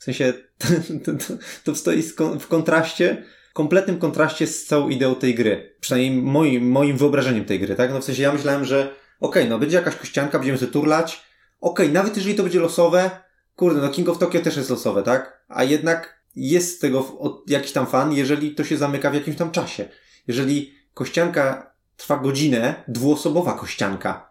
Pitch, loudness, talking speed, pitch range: 150 Hz, -21 LUFS, 190 wpm, 135-165 Hz